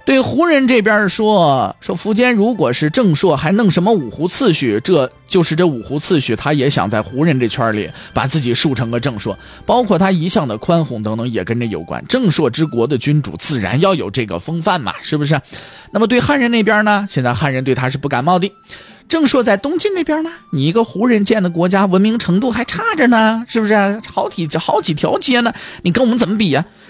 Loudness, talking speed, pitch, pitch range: -15 LUFS, 320 characters per minute, 180 Hz, 140-225 Hz